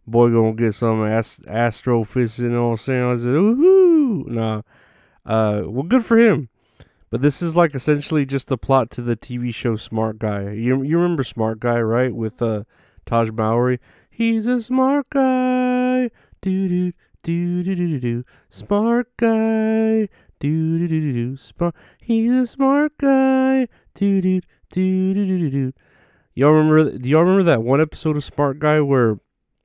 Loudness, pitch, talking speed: -19 LUFS, 145 Hz, 160 wpm